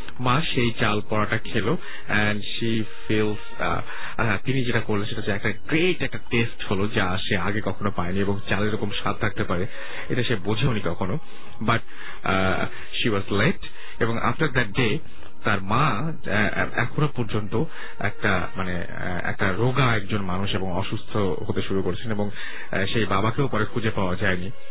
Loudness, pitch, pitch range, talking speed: -25 LUFS, 105 Hz, 100-120 Hz, 140 wpm